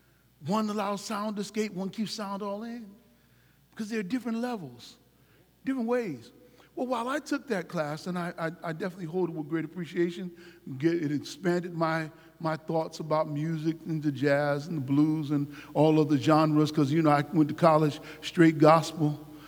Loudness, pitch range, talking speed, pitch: -28 LUFS, 150-200 Hz, 190 wpm, 165 Hz